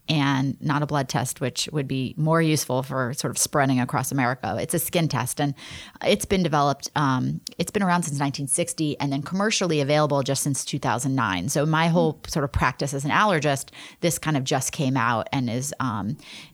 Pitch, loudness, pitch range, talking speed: 145 Hz, -24 LUFS, 130-155 Hz, 200 wpm